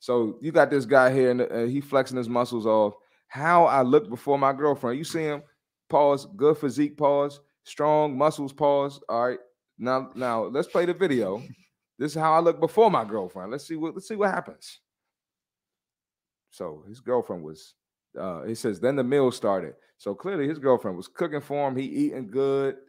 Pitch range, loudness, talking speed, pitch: 125-150 Hz, -25 LUFS, 190 wpm, 140 Hz